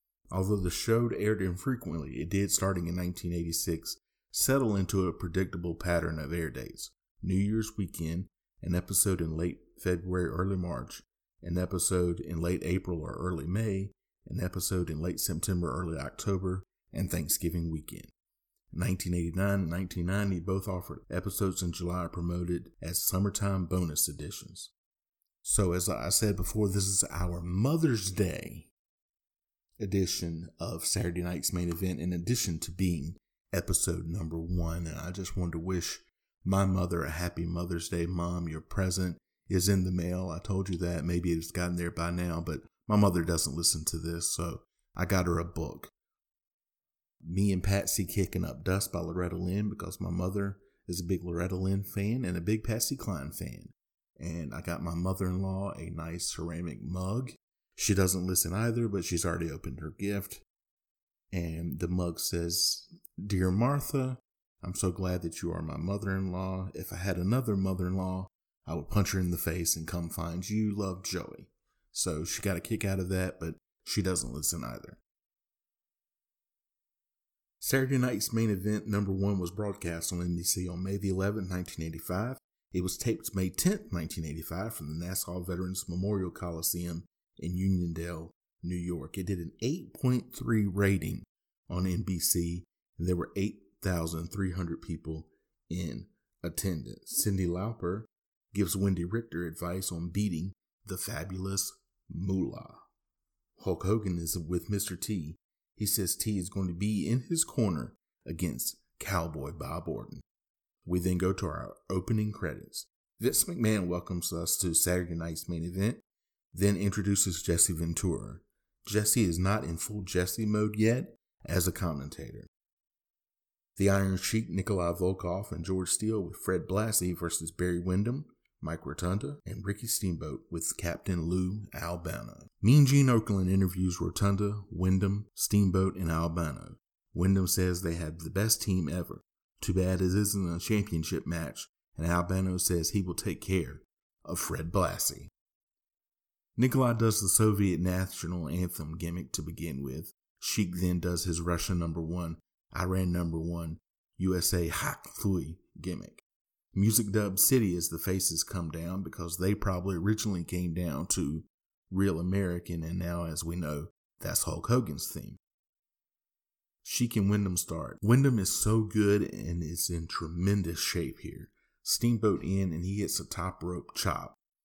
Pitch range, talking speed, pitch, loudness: 85-100 Hz, 155 wpm, 90 Hz, -31 LUFS